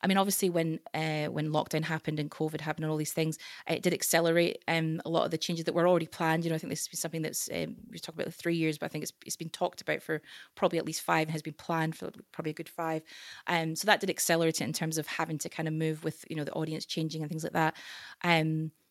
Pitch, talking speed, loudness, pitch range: 160 Hz, 290 wpm, -31 LUFS, 155-170 Hz